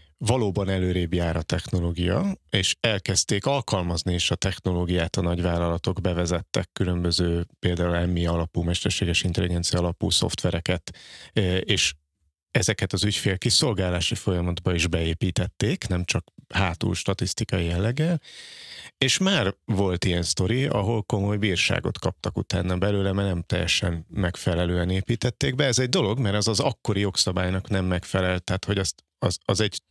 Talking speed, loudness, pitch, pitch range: 135 wpm, -24 LUFS, 95 Hz, 90-105 Hz